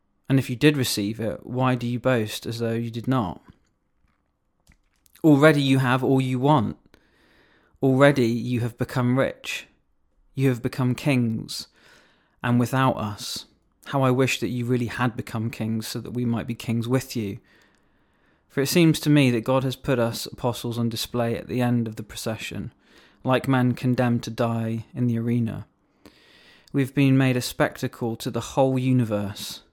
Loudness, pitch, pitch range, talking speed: -24 LUFS, 120 Hz, 115-130 Hz, 175 wpm